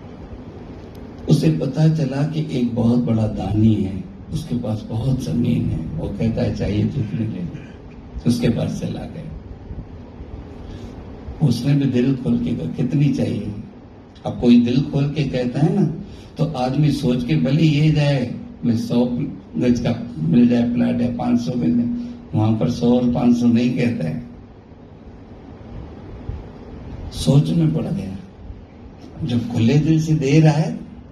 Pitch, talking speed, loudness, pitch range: 120 Hz, 150 wpm, -19 LUFS, 105-140 Hz